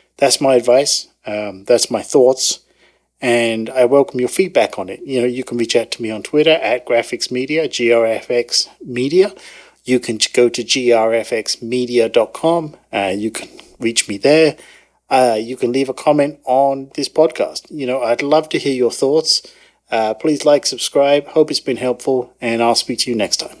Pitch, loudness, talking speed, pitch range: 125 Hz, -16 LUFS, 185 wpm, 120-150 Hz